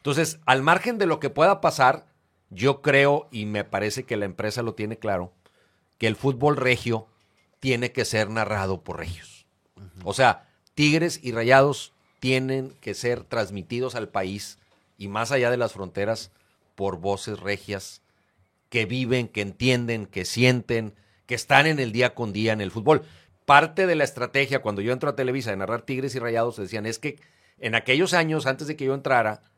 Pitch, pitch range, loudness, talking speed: 115 Hz, 100-135 Hz, -24 LUFS, 185 wpm